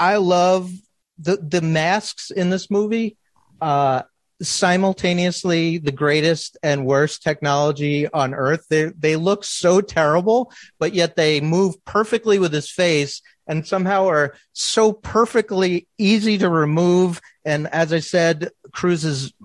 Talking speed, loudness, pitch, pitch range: 135 wpm, -19 LUFS, 170 Hz, 155-190 Hz